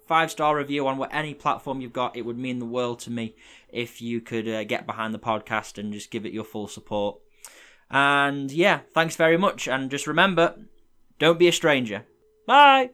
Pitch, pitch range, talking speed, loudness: 135 Hz, 115-165 Hz, 205 wpm, -23 LUFS